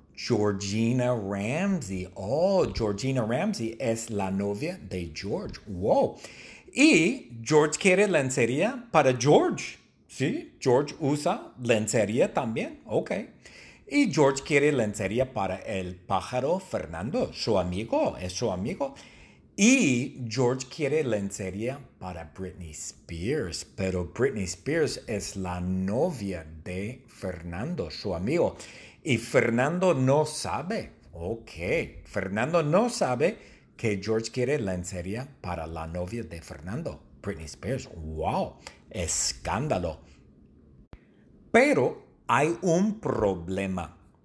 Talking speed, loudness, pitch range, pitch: 105 wpm, -27 LUFS, 90-130 Hz, 105 Hz